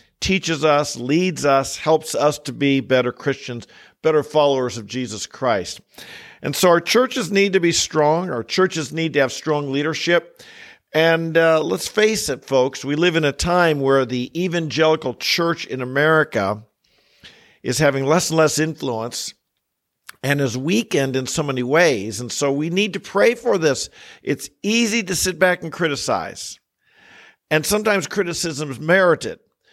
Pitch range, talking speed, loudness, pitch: 135-180 Hz, 160 wpm, -19 LUFS, 155 Hz